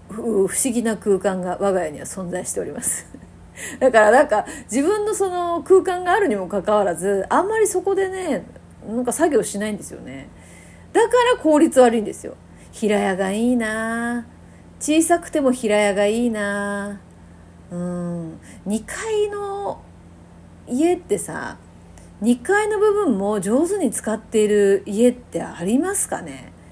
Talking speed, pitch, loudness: 275 characters per minute, 235 Hz, -20 LUFS